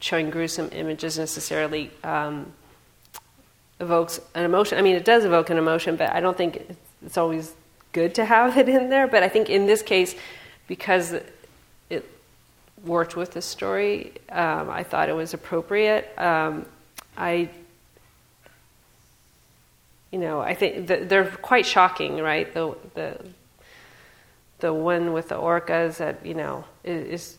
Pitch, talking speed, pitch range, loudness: 170 Hz, 145 wpm, 160-190 Hz, -23 LUFS